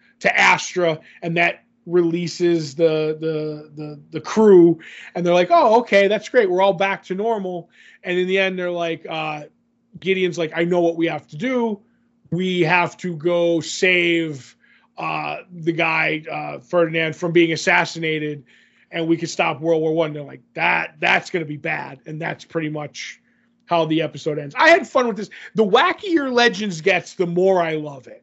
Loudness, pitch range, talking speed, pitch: -19 LUFS, 160-195 Hz, 185 wpm, 170 Hz